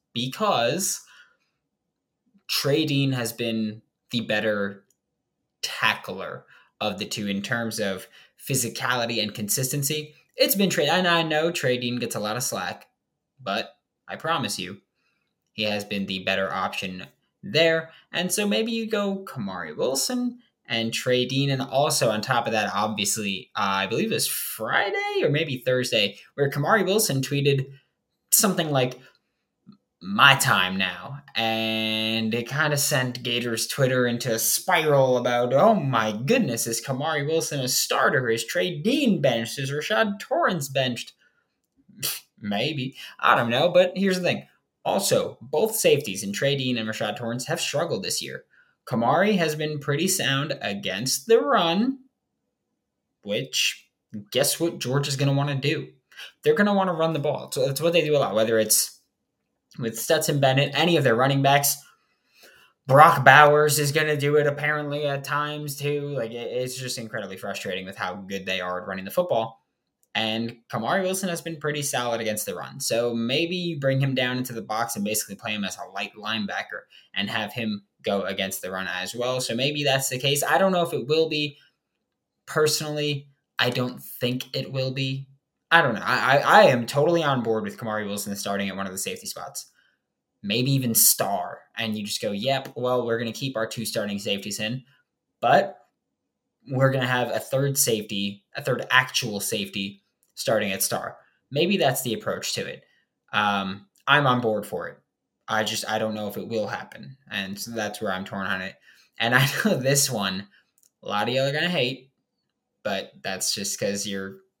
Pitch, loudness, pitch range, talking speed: 130 Hz, -24 LUFS, 110-150 Hz, 180 wpm